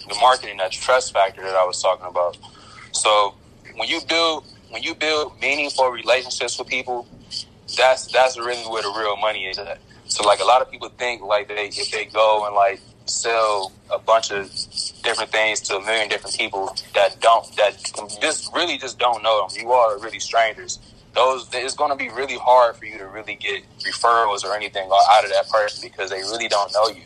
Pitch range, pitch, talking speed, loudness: 100-125 Hz, 110 Hz, 205 wpm, -20 LUFS